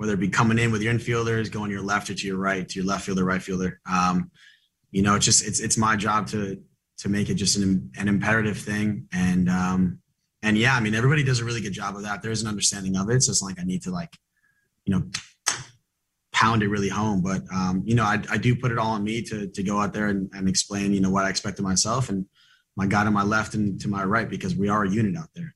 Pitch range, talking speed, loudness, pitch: 95-110 Hz, 275 wpm, -24 LUFS, 105 Hz